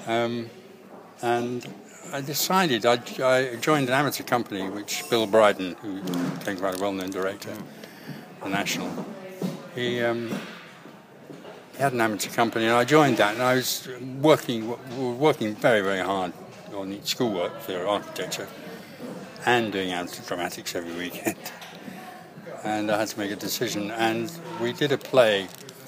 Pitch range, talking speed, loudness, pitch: 100-135 Hz, 150 wpm, -25 LUFS, 120 Hz